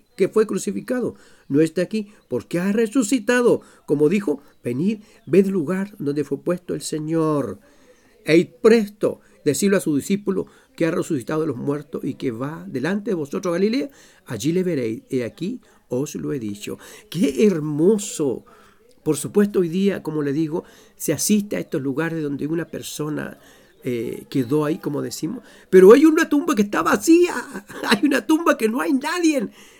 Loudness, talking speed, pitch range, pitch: -21 LUFS, 165 wpm, 150-225 Hz, 185 Hz